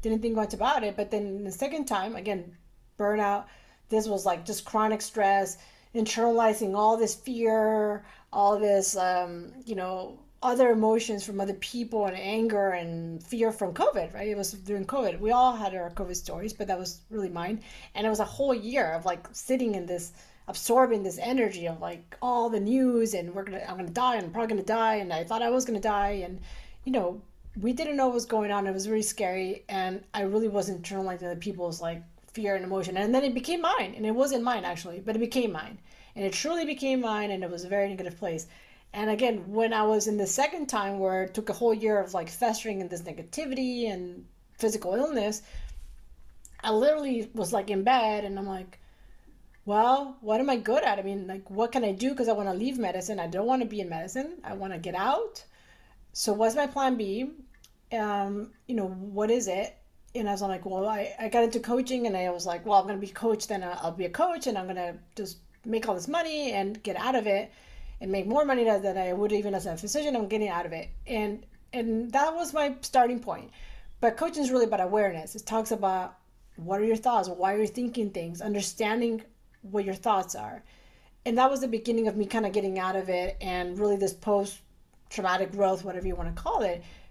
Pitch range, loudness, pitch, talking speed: 190-230 Hz, -29 LUFS, 210 Hz, 225 wpm